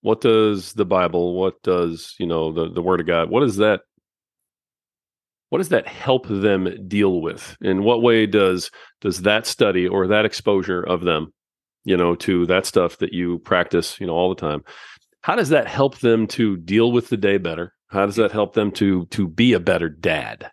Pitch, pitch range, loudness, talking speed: 95 Hz, 90-110 Hz, -20 LUFS, 205 wpm